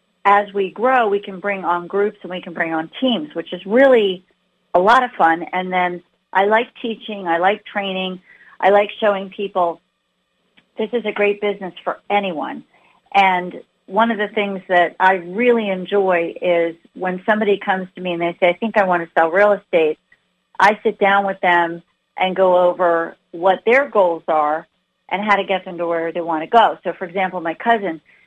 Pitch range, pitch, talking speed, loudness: 175-205 Hz, 190 Hz, 200 wpm, -18 LUFS